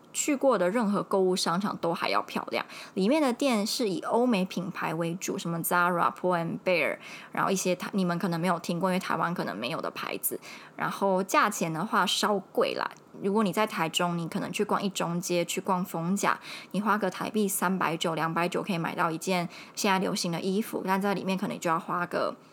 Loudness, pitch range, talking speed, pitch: -28 LUFS, 175-205 Hz, 335 characters per minute, 190 Hz